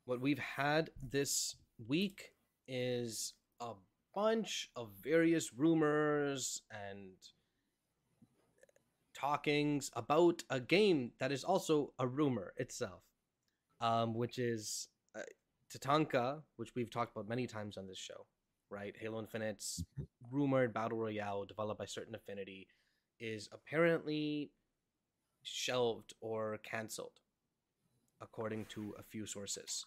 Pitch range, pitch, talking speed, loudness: 110-145 Hz, 120 Hz, 115 wpm, -38 LUFS